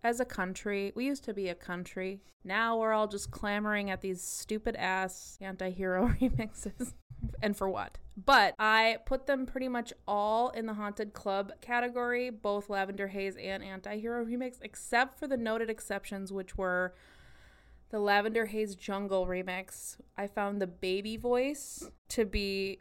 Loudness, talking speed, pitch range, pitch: -33 LUFS, 165 wpm, 190-230 Hz, 205 Hz